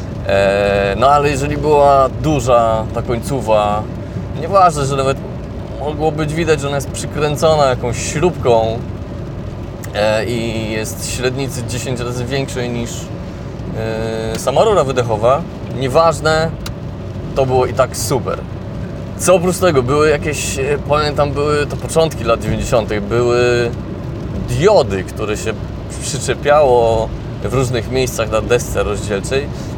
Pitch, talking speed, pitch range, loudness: 120 Hz, 115 wpm, 110-145 Hz, -16 LUFS